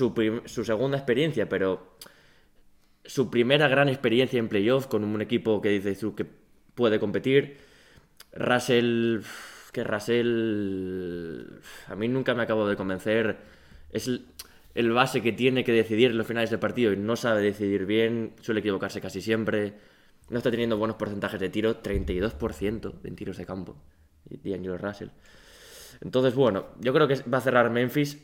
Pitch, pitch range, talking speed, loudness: 110 Hz, 100-120 Hz, 155 wpm, -26 LUFS